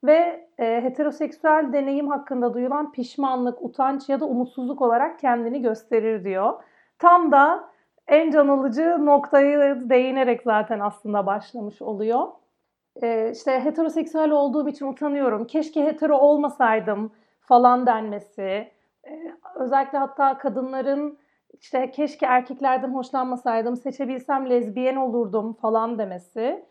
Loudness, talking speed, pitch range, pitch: -22 LUFS, 105 wpm, 235-290 Hz, 265 Hz